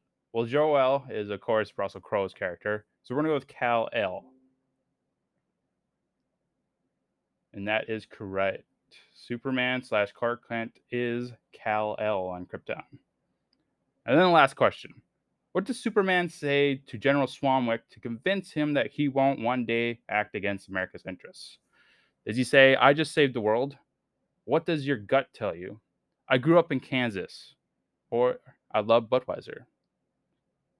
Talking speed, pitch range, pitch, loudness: 150 wpm, 110-140 Hz, 125 Hz, -27 LUFS